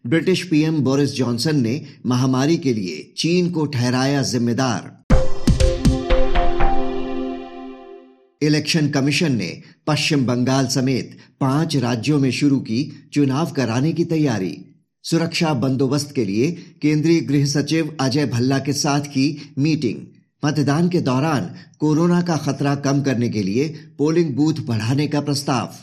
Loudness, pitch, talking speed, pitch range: -20 LUFS, 140 Hz, 130 wpm, 130-155 Hz